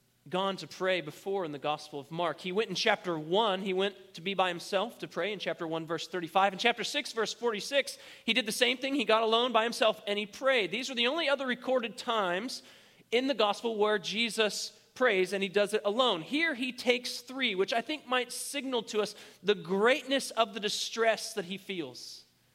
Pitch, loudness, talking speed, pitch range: 215 Hz, -30 LUFS, 220 wpm, 190-245 Hz